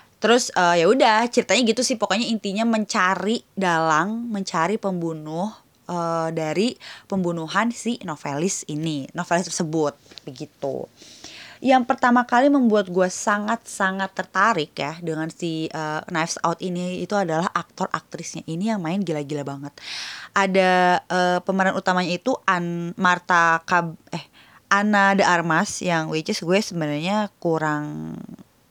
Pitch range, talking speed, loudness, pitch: 160-205 Hz, 135 wpm, -22 LUFS, 180 Hz